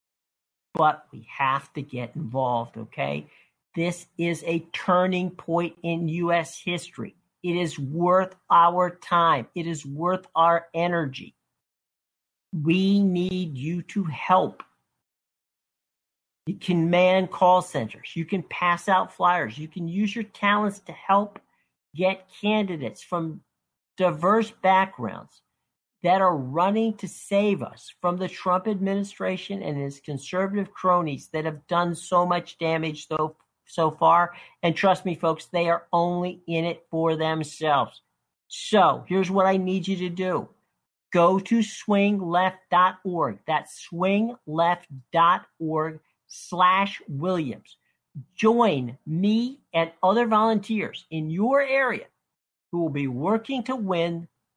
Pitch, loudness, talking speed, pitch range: 175 Hz, -24 LUFS, 125 wpm, 160-190 Hz